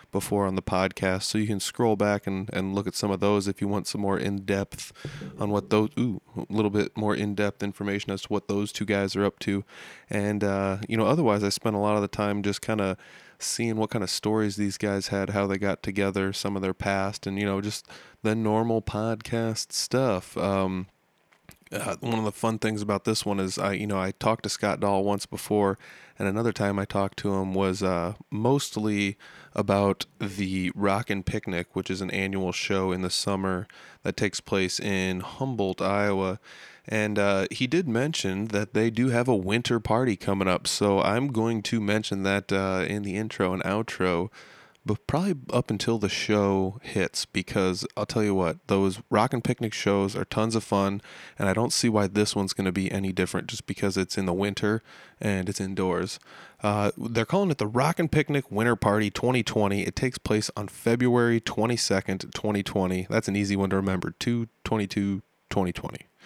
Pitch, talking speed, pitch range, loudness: 100 Hz, 205 wpm, 95-110 Hz, -27 LUFS